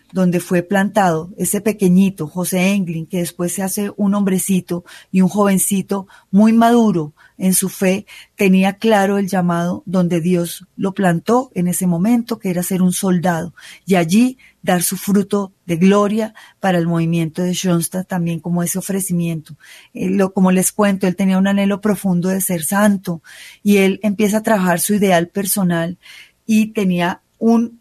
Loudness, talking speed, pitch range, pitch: -17 LUFS, 160 wpm, 180-205 Hz, 190 Hz